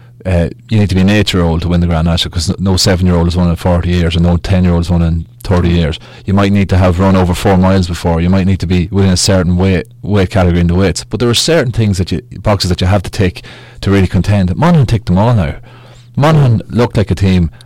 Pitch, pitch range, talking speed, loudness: 95 Hz, 90-110 Hz, 285 wpm, -12 LUFS